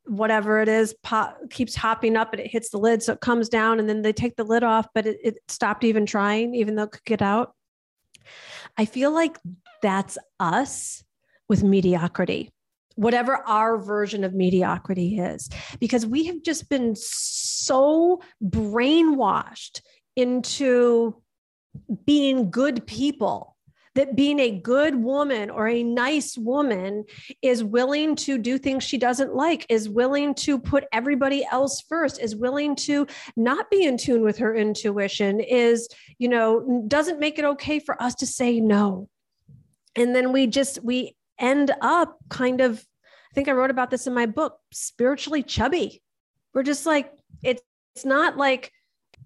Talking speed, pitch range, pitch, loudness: 160 wpm, 220-280 Hz, 245 Hz, -23 LUFS